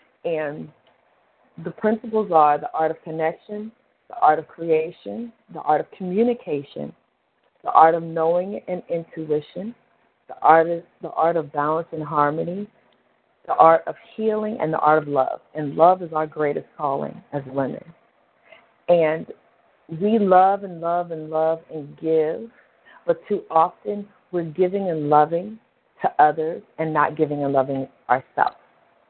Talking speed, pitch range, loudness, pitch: 150 wpm, 155-200 Hz, -21 LUFS, 165 Hz